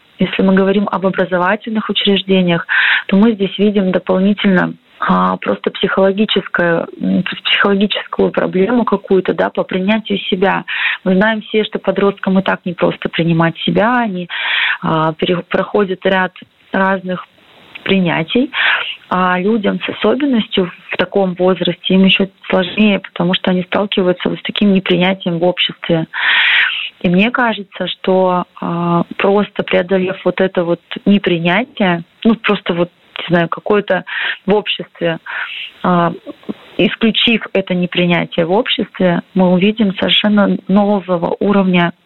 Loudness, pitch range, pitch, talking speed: -14 LUFS, 180-205 Hz, 190 Hz, 125 wpm